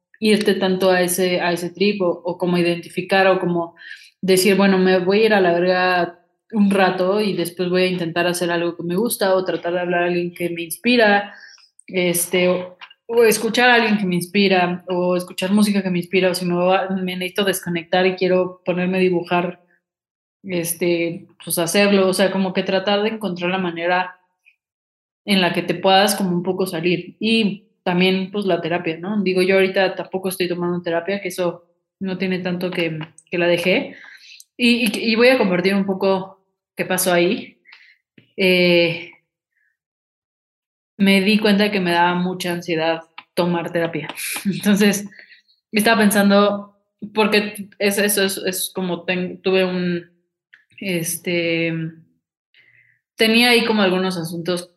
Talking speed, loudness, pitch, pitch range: 170 wpm, -18 LUFS, 185 Hz, 175-195 Hz